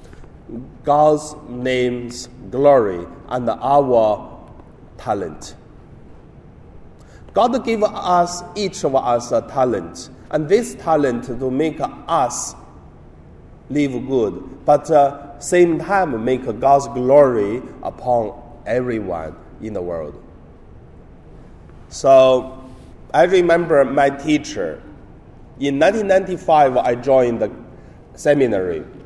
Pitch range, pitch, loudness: 125-155 Hz, 140 Hz, -18 LUFS